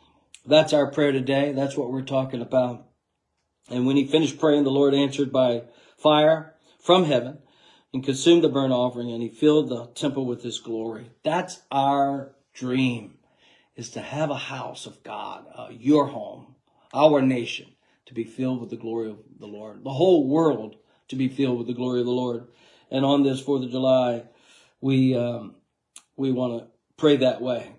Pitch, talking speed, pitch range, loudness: 130 Hz, 180 wpm, 120-140 Hz, -23 LUFS